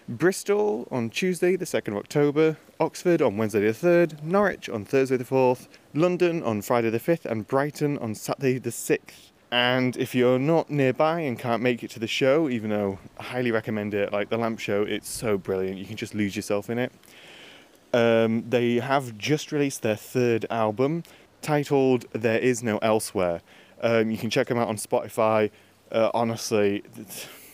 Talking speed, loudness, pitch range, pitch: 180 wpm, -25 LUFS, 110-140 Hz, 120 Hz